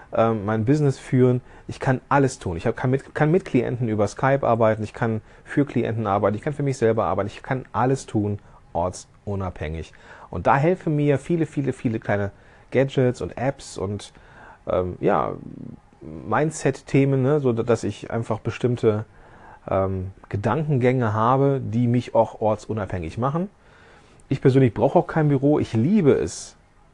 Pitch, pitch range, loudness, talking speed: 120 Hz, 105-135 Hz, -22 LUFS, 155 wpm